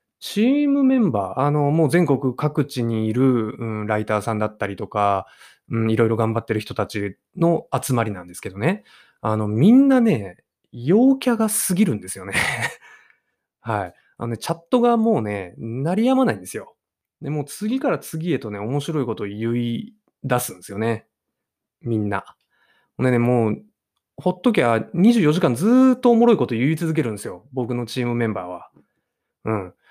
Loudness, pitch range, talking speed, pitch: -21 LUFS, 110-180 Hz, 335 characters per minute, 125 Hz